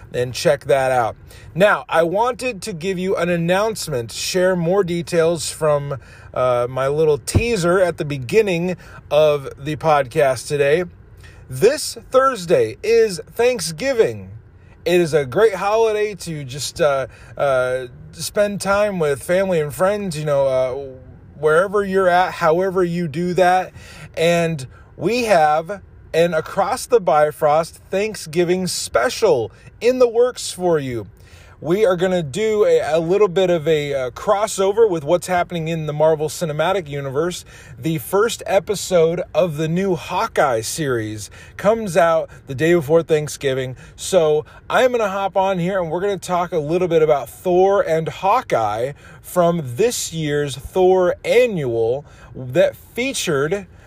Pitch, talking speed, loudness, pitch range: 170 Hz, 145 wpm, -18 LUFS, 140-195 Hz